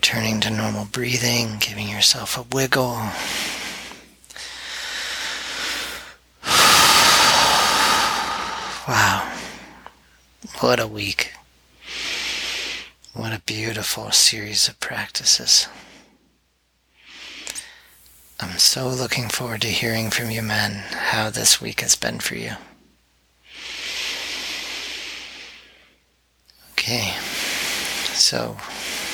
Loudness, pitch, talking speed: -19 LUFS, 115 Hz, 75 wpm